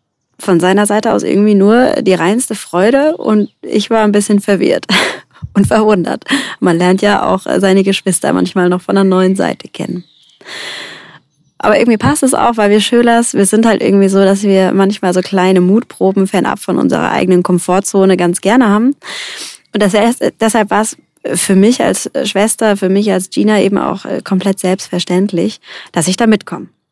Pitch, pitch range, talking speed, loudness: 200 Hz, 185-215 Hz, 170 wpm, -11 LUFS